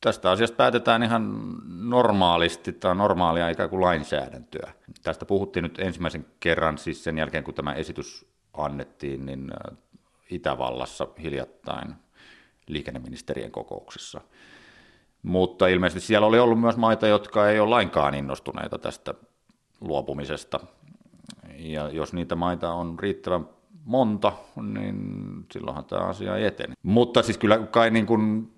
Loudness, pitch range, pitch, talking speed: -25 LUFS, 85-110 Hz, 95 Hz, 125 wpm